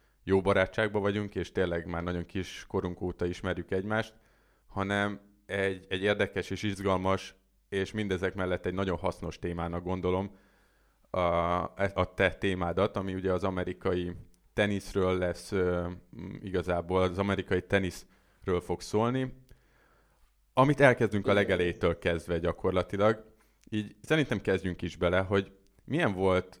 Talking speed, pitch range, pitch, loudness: 125 wpm, 90-100 Hz, 95 Hz, -30 LUFS